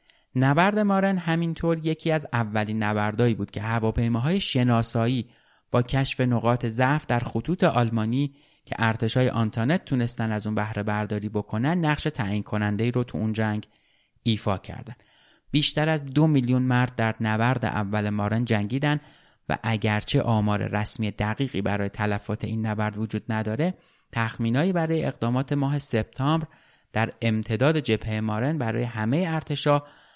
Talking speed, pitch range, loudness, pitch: 140 wpm, 110-140 Hz, -25 LUFS, 115 Hz